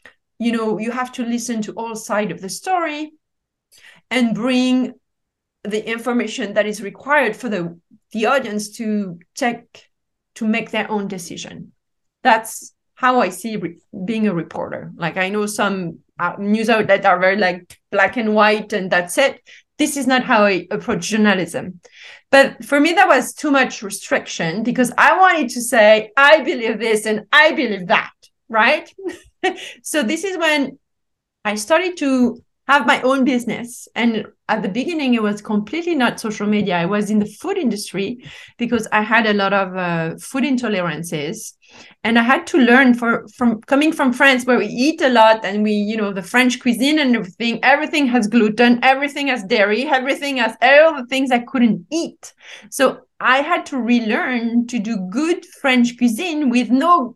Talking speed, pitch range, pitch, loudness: 175 wpm, 210-270 Hz, 235 Hz, -17 LUFS